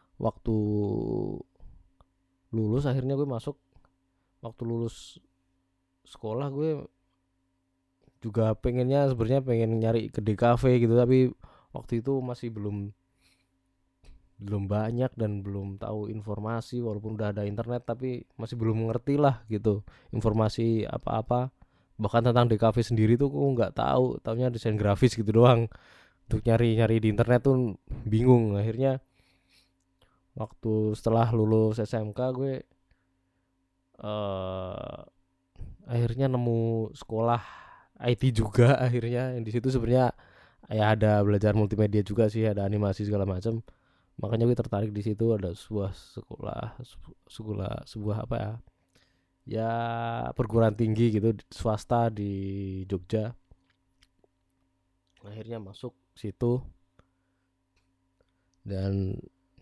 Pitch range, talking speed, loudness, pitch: 95-120 Hz, 110 wpm, -28 LUFS, 110 Hz